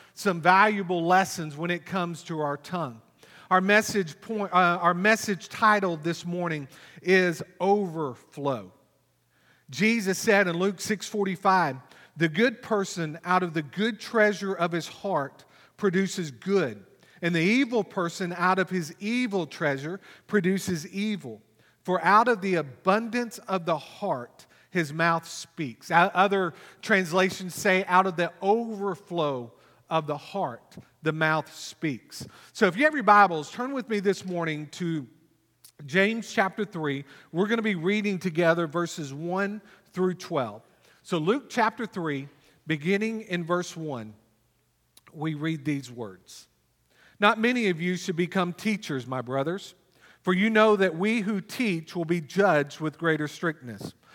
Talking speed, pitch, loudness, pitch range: 145 wpm, 180 Hz, -26 LUFS, 160-200 Hz